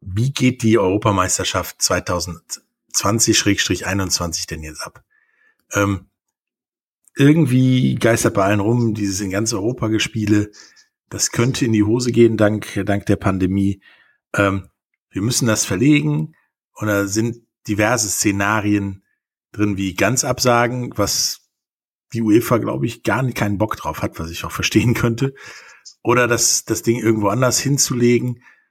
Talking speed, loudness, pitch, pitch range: 135 wpm, -18 LUFS, 110 Hz, 100-125 Hz